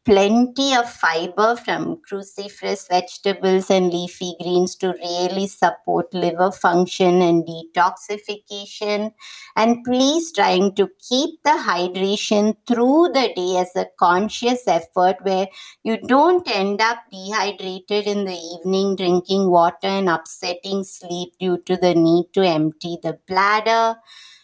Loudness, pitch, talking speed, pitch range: -19 LUFS, 195 Hz, 130 wpm, 180-215 Hz